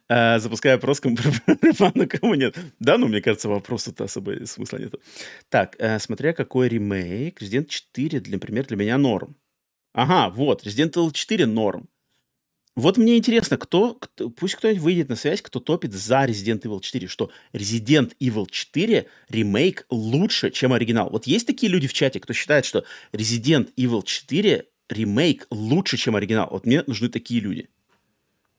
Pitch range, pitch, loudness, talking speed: 110-150 Hz, 125 Hz, -22 LUFS, 165 wpm